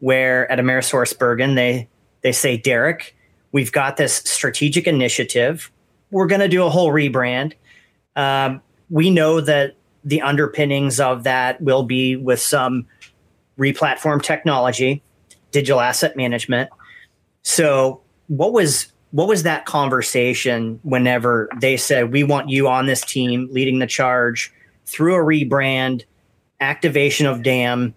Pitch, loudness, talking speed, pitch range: 130 Hz, -18 LUFS, 135 wpm, 125-145 Hz